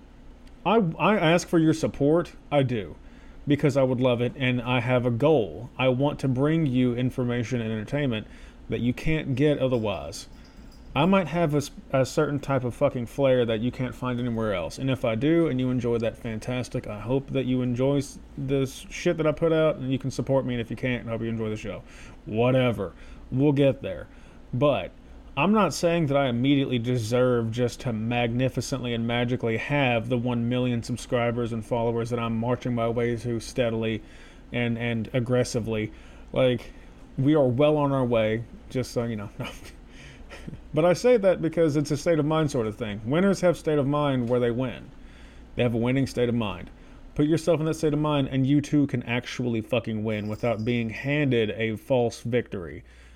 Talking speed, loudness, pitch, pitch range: 200 wpm, -25 LUFS, 125 Hz, 115-145 Hz